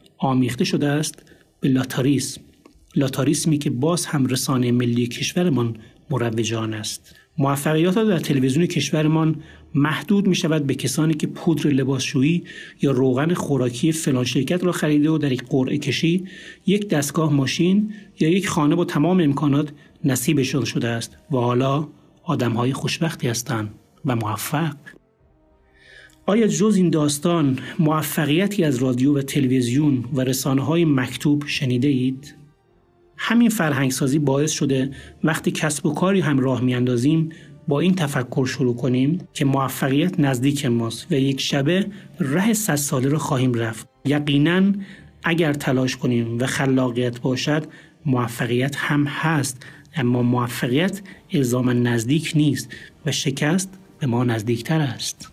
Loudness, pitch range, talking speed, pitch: -21 LUFS, 130-160 Hz, 135 wpm, 145 Hz